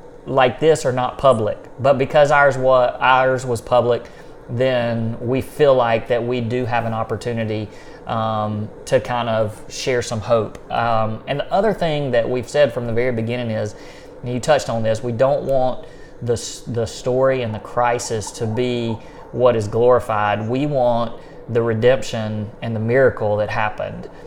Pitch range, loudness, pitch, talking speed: 115-130 Hz, -19 LUFS, 120 Hz, 170 wpm